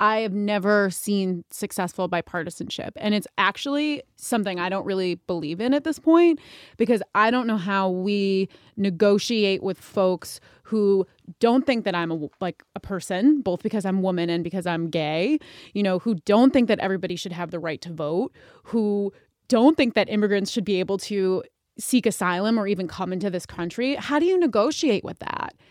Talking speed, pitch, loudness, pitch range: 185 wpm, 200 Hz, -23 LUFS, 185-225 Hz